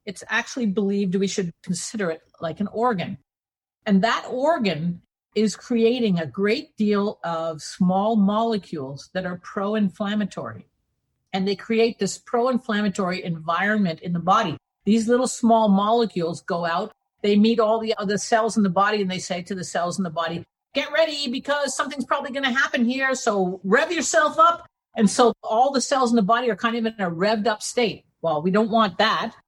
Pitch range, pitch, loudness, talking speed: 190-235 Hz, 210 Hz, -22 LUFS, 190 wpm